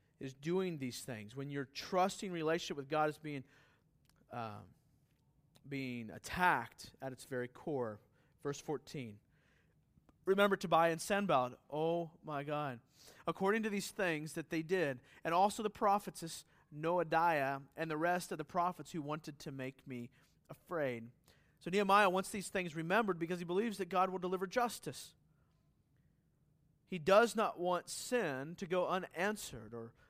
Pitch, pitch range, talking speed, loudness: 160 Hz, 140-185 Hz, 150 wpm, -37 LUFS